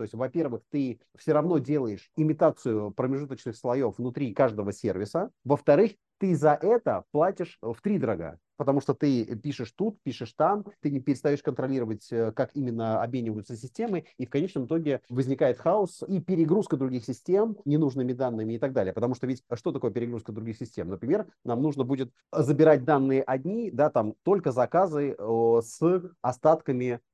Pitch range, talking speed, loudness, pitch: 120-155 Hz, 160 wpm, -27 LUFS, 135 Hz